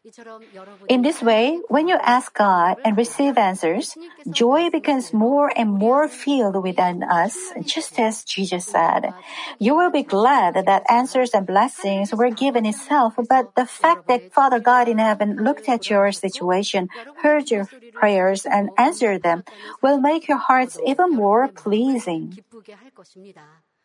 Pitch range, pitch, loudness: 200-270 Hz, 235 Hz, -19 LUFS